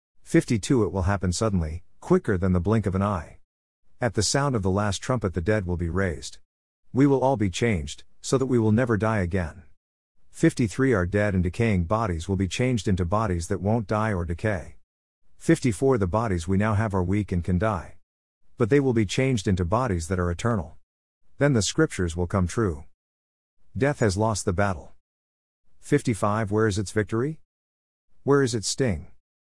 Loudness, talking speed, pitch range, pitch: -25 LUFS, 190 wpm, 90-115 Hz, 100 Hz